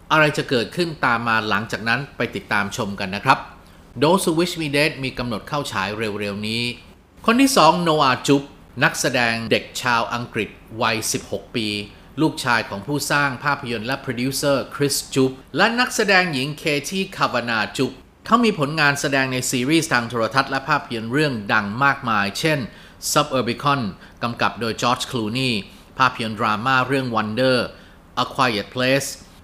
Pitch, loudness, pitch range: 130 Hz, -20 LUFS, 110-145 Hz